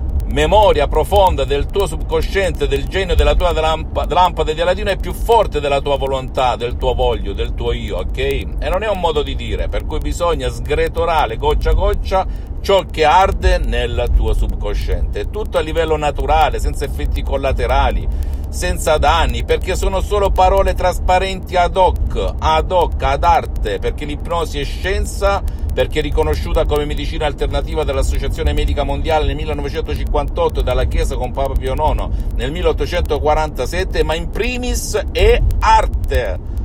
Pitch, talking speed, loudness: 160 Hz, 155 wpm, -17 LUFS